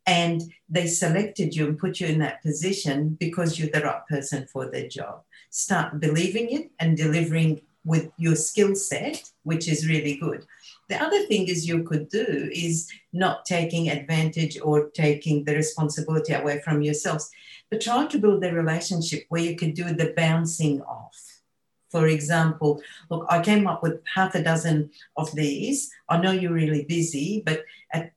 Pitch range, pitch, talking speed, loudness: 155-175 Hz, 165 Hz, 175 wpm, -25 LUFS